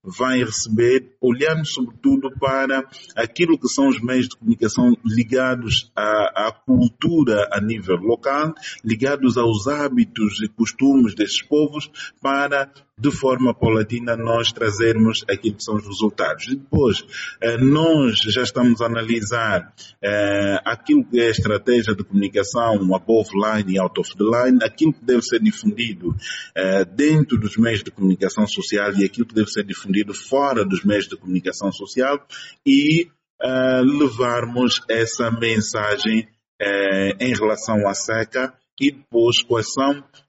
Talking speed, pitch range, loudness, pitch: 140 wpm, 110-135 Hz, -19 LUFS, 120 Hz